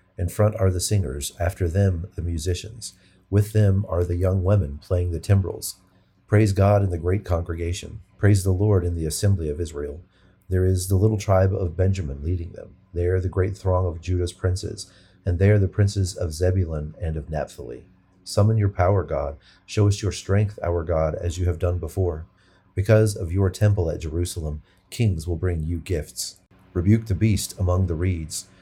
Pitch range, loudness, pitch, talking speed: 85-100 Hz, -23 LUFS, 95 Hz, 185 wpm